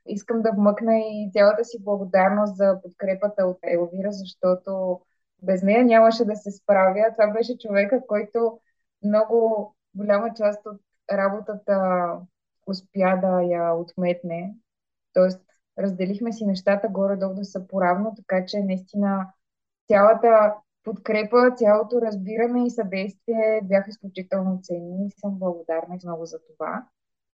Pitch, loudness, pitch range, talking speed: 200 Hz, -22 LUFS, 190-215 Hz, 125 wpm